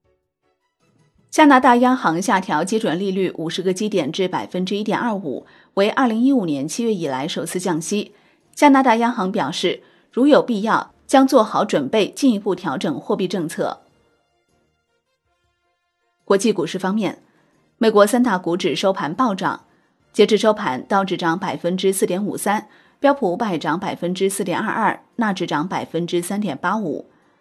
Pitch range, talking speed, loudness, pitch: 175-225 Hz, 250 characters per minute, -19 LUFS, 195 Hz